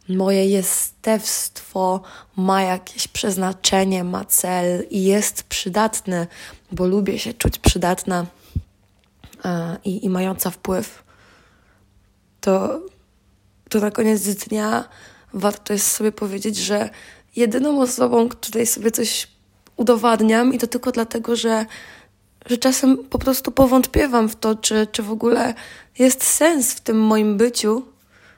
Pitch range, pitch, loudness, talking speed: 190-235 Hz, 215 Hz, -19 LUFS, 120 wpm